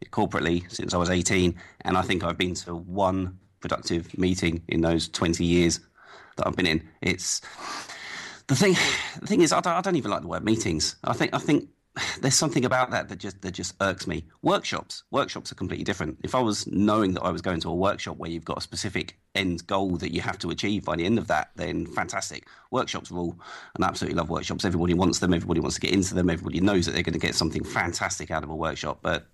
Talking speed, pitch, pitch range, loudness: 240 wpm, 90 Hz, 85-95 Hz, -26 LUFS